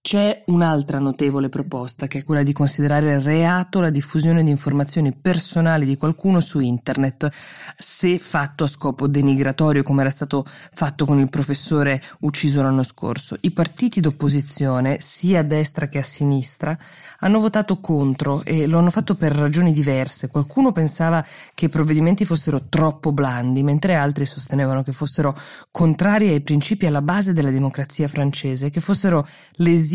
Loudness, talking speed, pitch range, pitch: -20 LUFS, 155 wpm, 140-170 Hz, 150 Hz